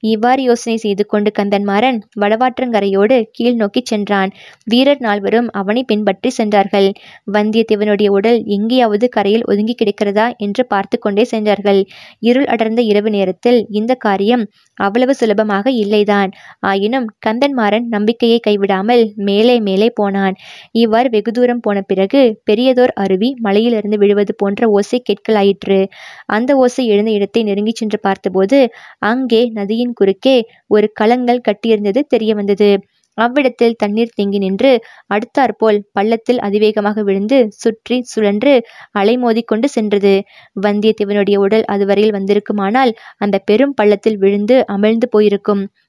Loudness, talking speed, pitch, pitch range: -14 LUFS, 120 wpm, 215 Hz, 205-235 Hz